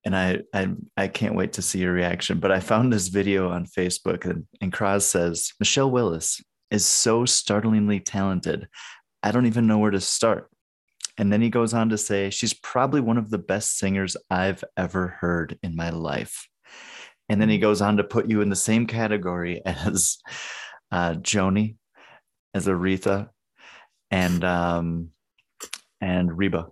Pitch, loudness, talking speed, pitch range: 100 Hz, -23 LUFS, 170 wpm, 90-110 Hz